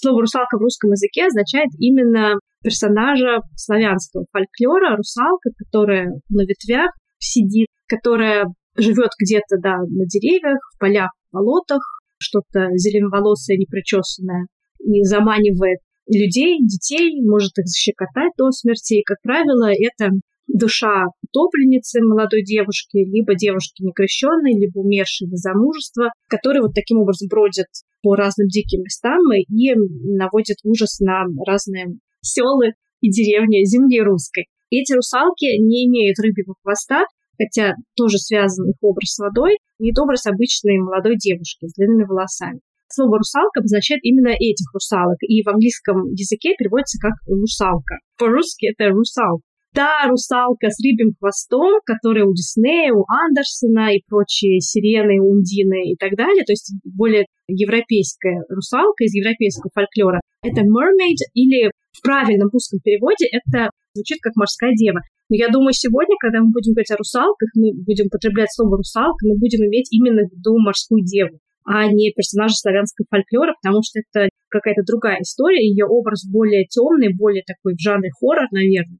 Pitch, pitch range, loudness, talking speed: 215 Hz, 200-240 Hz, -16 LUFS, 145 wpm